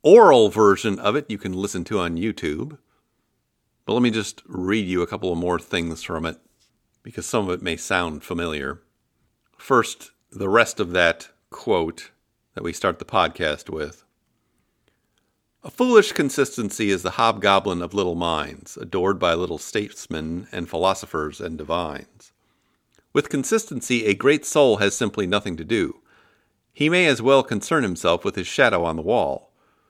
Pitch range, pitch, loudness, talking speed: 90-130 Hz, 100 Hz, -21 LUFS, 165 wpm